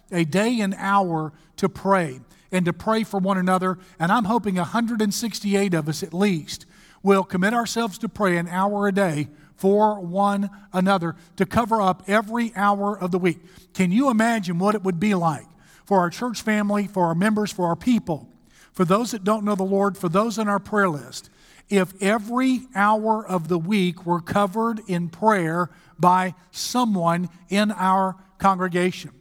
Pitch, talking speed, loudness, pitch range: 195 Hz, 175 wpm, -22 LUFS, 180-210 Hz